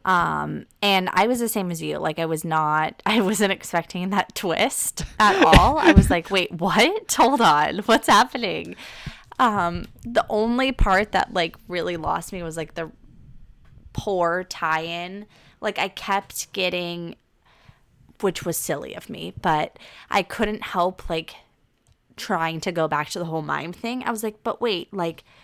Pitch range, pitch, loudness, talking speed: 165-210 Hz, 185 Hz, -22 LUFS, 165 wpm